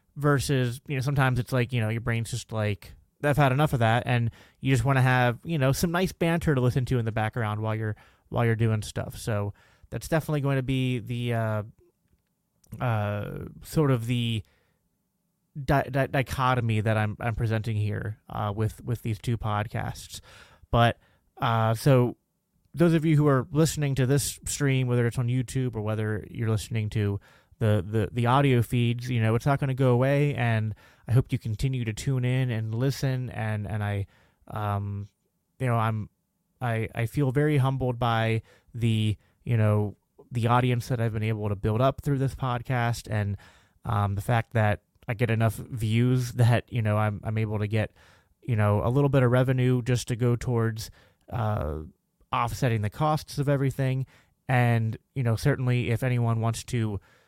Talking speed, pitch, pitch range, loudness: 185 wpm, 120 Hz, 110-130 Hz, -27 LUFS